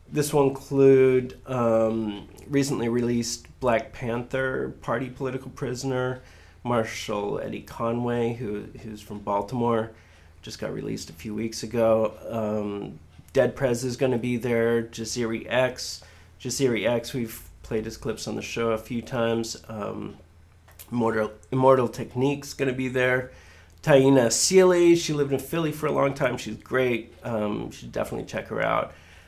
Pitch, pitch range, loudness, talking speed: 115 Hz, 105-130 Hz, -25 LUFS, 150 wpm